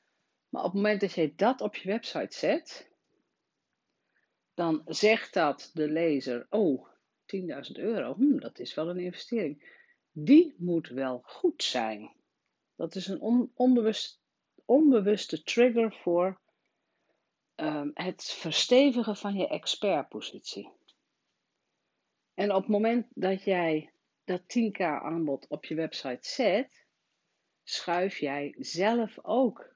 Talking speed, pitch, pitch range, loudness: 115 wpm, 185 Hz, 160-225 Hz, -29 LUFS